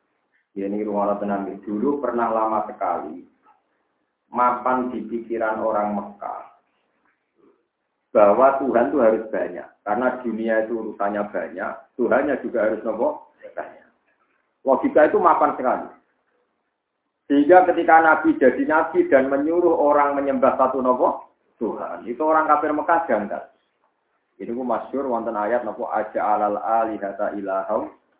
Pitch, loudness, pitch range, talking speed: 115 Hz, -21 LUFS, 105-140 Hz, 130 wpm